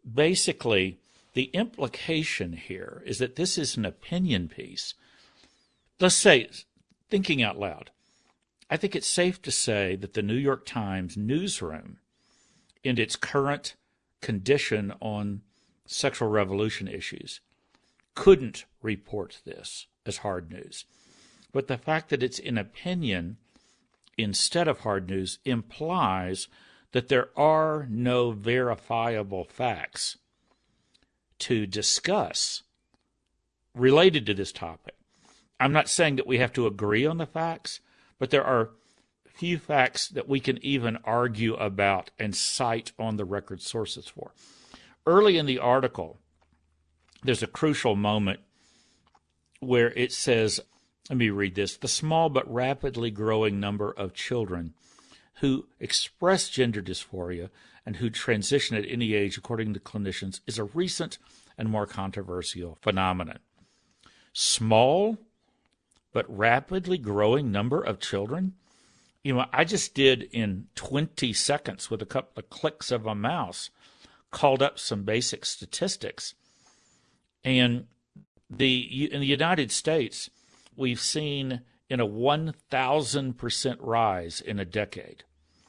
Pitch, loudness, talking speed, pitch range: 120 Hz, -27 LUFS, 125 wpm, 105-140 Hz